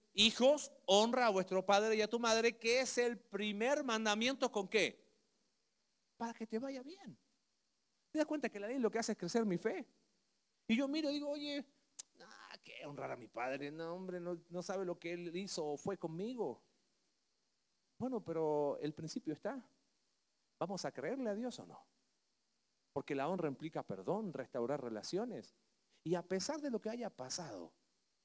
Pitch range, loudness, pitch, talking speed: 175-250 Hz, -39 LUFS, 215 Hz, 180 wpm